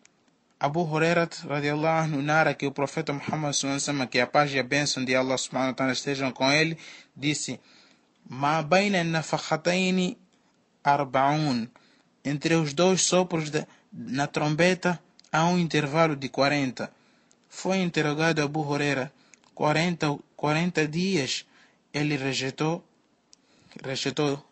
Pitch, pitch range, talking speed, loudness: 150 Hz, 140-165 Hz, 115 wpm, -26 LUFS